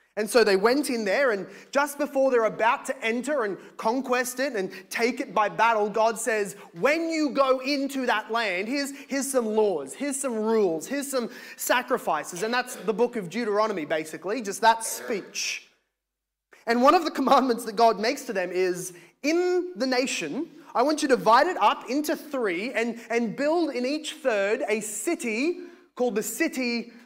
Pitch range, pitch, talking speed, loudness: 220-280 Hz, 245 Hz, 185 wpm, -25 LUFS